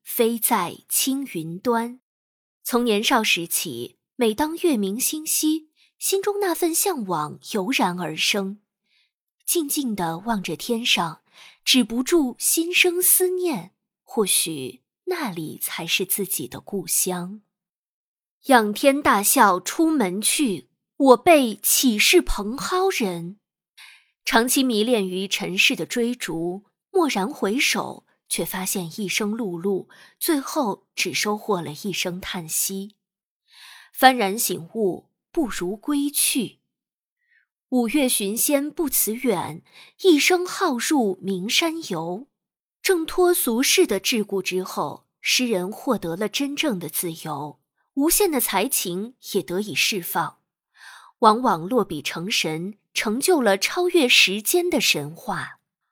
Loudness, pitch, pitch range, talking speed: -21 LUFS, 220 Hz, 185-290 Hz, 175 characters per minute